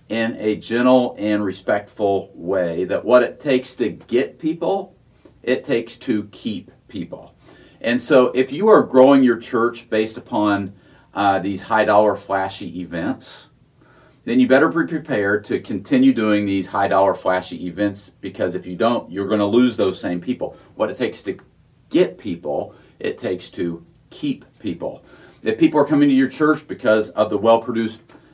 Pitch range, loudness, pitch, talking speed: 100-130 Hz, -19 LUFS, 110 Hz, 170 wpm